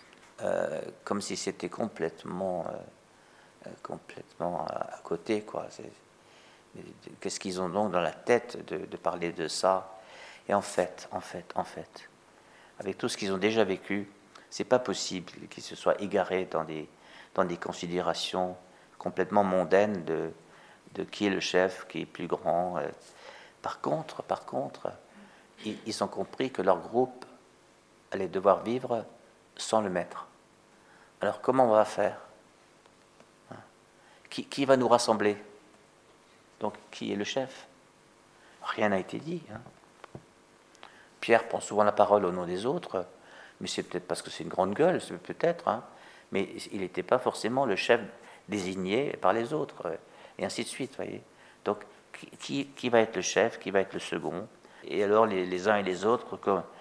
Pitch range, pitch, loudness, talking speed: 90-115 Hz, 100 Hz, -30 LUFS, 165 wpm